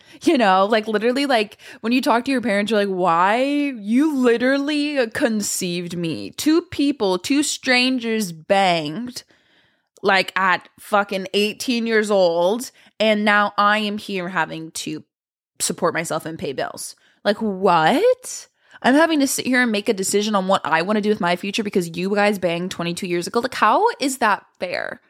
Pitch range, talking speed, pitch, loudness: 190-255 Hz, 175 wpm, 210 Hz, -19 LUFS